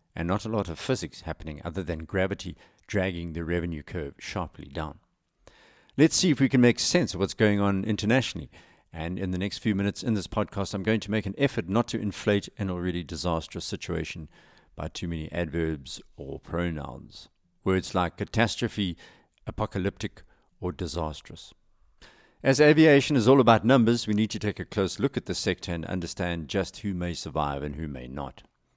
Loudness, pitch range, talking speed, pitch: -27 LUFS, 85-110 Hz, 185 wpm, 95 Hz